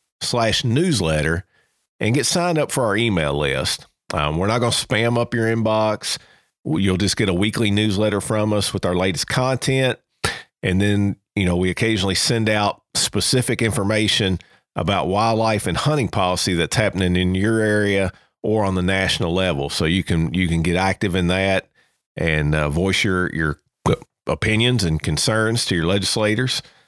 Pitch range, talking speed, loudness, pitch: 90-110 Hz, 170 wpm, -20 LUFS, 100 Hz